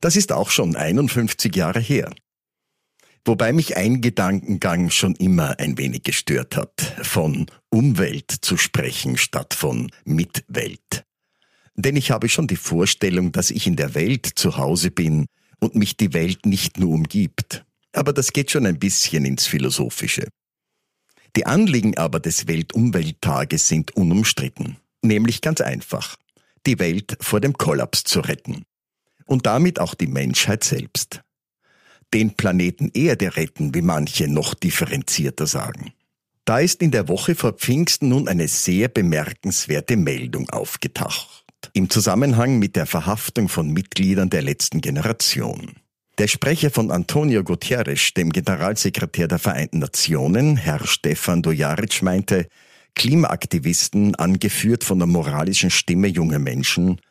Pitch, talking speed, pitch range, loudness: 100 Hz, 135 wpm, 85-125 Hz, -20 LUFS